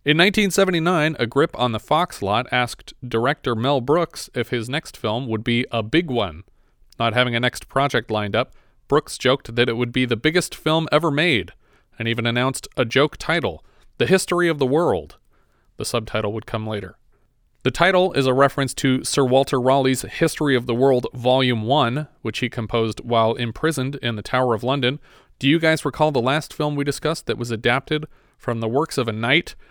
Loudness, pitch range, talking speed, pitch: -21 LUFS, 115-150 Hz, 200 wpm, 130 Hz